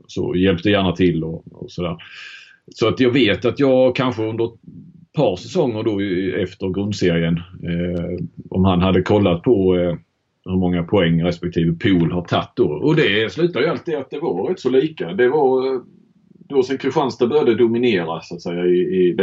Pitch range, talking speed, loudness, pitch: 90-130 Hz, 185 wpm, -19 LUFS, 95 Hz